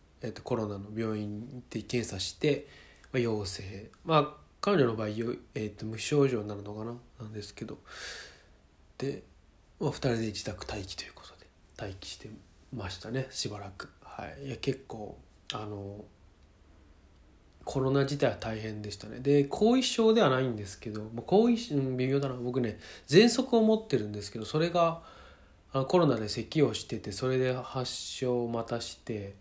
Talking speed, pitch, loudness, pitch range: 295 characters per minute, 115 Hz, -31 LUFS, 105-135 Hz